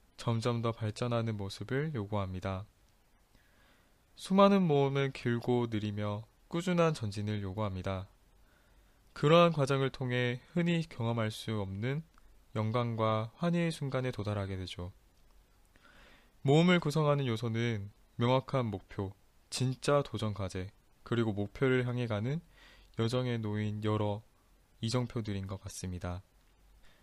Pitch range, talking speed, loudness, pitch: 100-130 Hz, 260 characters per minute, -33 LUFS, 115 Hz